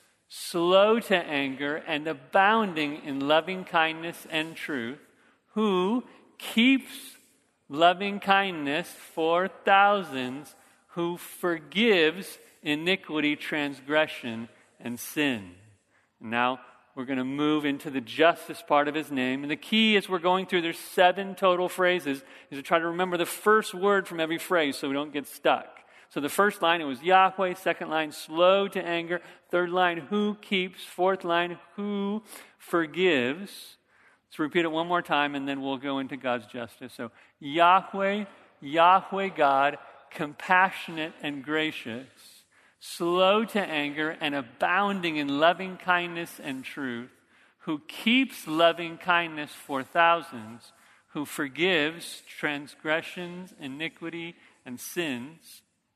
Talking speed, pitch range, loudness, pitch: 130 wpm, 145-185 Hz, -26 LUFS, 170 Hz